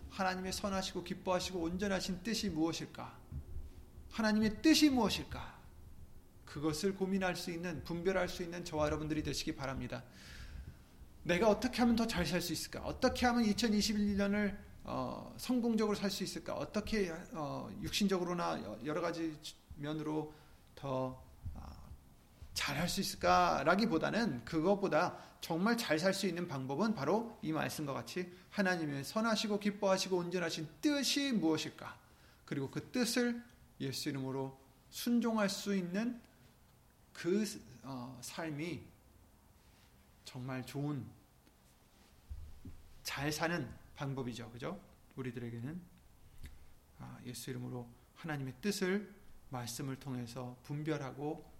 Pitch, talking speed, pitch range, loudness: 165 Hz, 270 characters per minute, 130-200 Hz, -37 LUFS